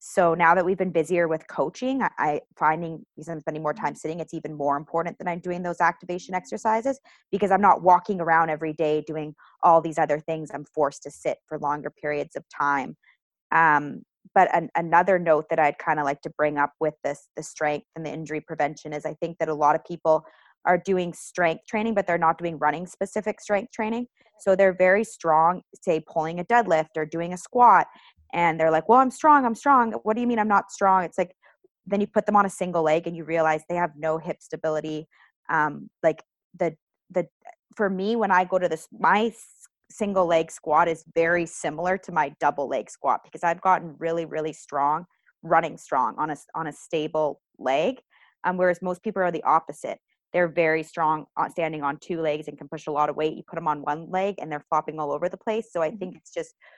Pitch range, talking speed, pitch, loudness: 155-185 Hz, 230 wpm, 165 Hz, -24 LUFS